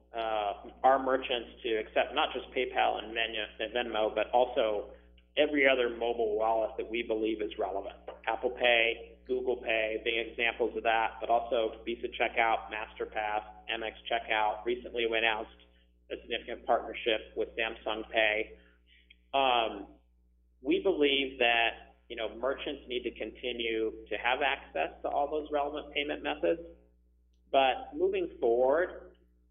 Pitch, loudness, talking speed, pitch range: 115 Hz, -31 LUFS, 135 wpm, 105-125 Hz